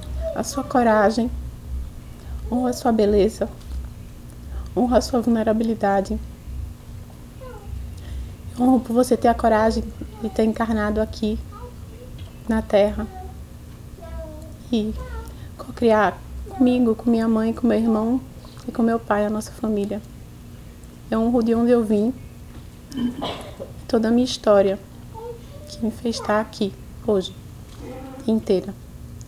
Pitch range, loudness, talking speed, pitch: 200-235 Hz, -21 LUFS, 115 wpm, 220 Hz